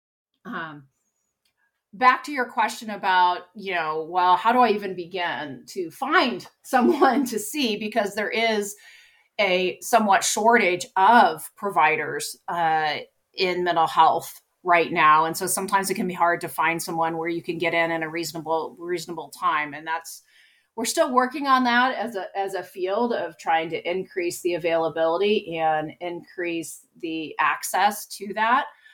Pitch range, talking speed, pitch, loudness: 165-220 Hz, 160 wpm, 180 Hz, -23 LUFS